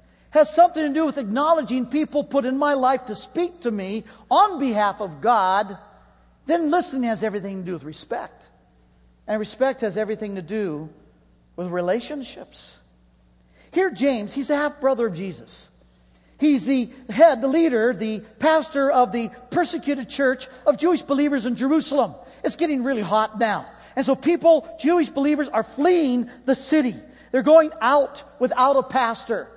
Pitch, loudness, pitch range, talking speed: 255 Hz, -21 LUFS, 210-295 Hz, 160 wpm